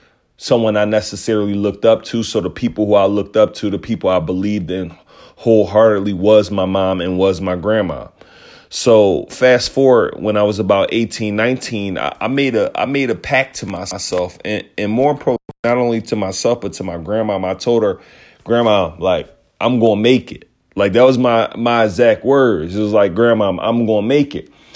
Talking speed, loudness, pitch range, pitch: 195 wpm, -15 LUFS, 100-120 Hz, 110 Hz